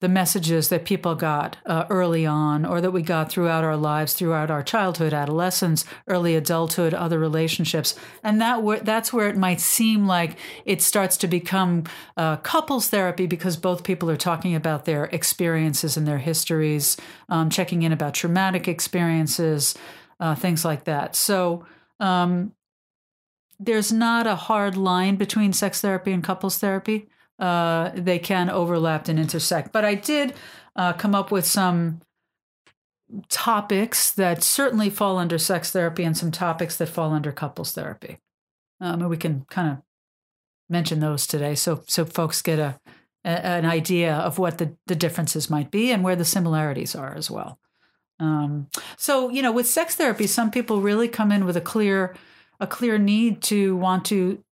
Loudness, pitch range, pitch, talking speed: -22 LUFS, 160-200 Hz, 175 Hz, 170 wpm